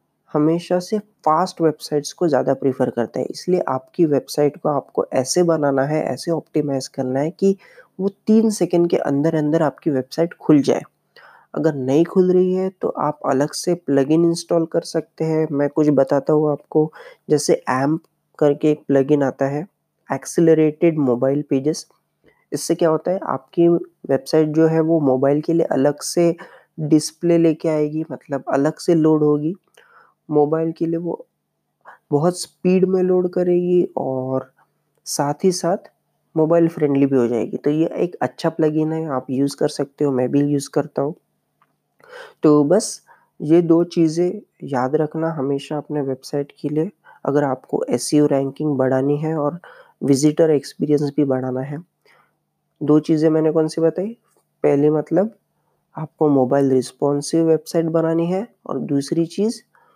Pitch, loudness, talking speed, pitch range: 155 Hz, -19 LUFS, 160 wpm, 140-170 Hz